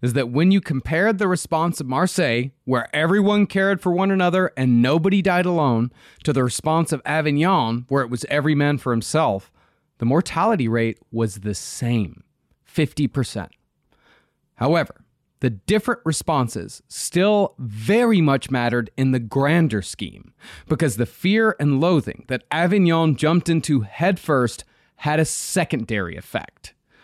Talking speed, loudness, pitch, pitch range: 140 wpm, -20 LUFS, 150 Hz, 120-175 Hz